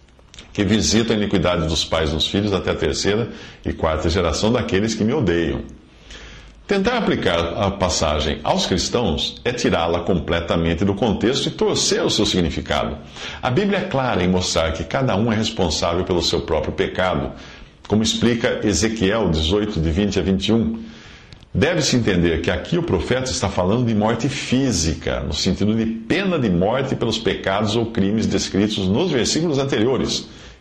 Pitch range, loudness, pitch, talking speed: 85-110 Hz, -20 LUFS, 95 Hz, 165 wpm